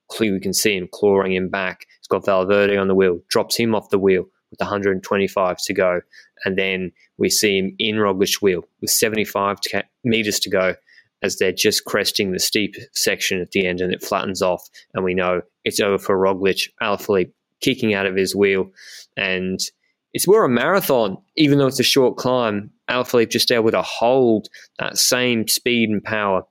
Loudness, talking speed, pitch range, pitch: -19 LUFS, 190 wpm, 95-110 Hz, 100 Hz